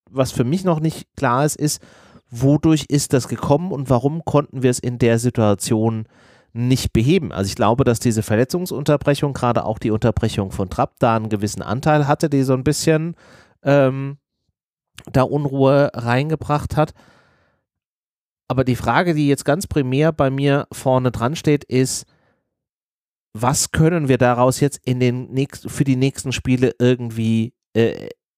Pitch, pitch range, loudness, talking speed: 130 Hz, 120-145 Hz, -19 LUFS, 160 wpm